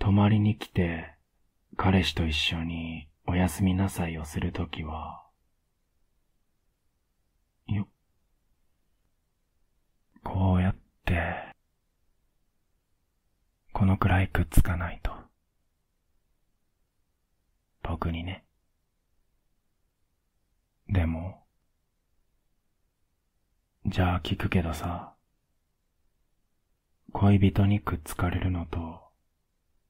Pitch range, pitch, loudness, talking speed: 80-95 Hz, 90 Hz, -28 LUFS, 135 characters per minute